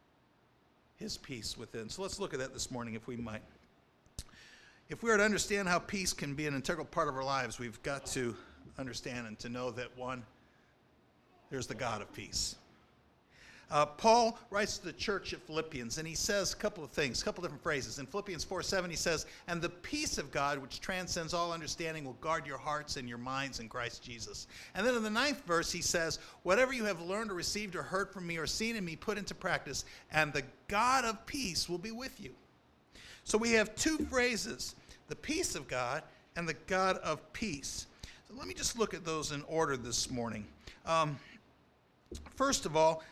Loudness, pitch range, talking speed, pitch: -35 LUFS, 130-195 Hz, 205 wpm, 160 Hz